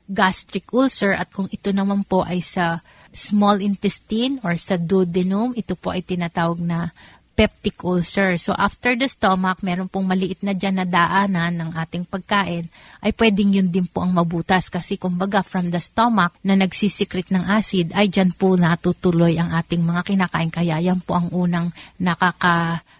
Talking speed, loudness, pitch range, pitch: 170 wpm, -20 LUFS, 175-200 Hz, 185 Hz